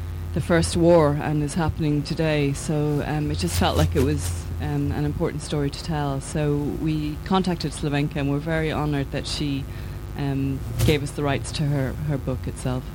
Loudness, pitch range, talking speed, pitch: -24 LUFS, 115-150 Hz, 190 wpm, 140 Hz